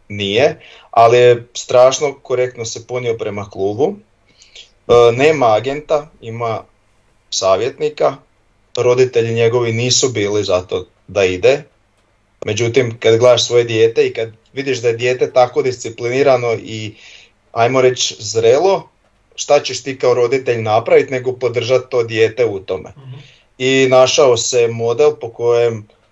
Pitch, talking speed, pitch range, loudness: 125 Hz, 125 wpm, 115-135 Hz, -14 LUFS